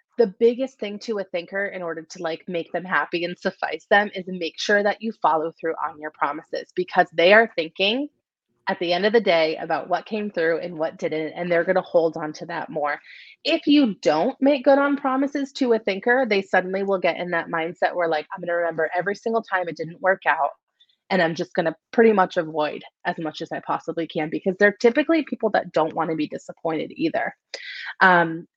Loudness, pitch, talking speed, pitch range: -22 LUFS, 185 Hz, 220 wpm, 165-225 Hz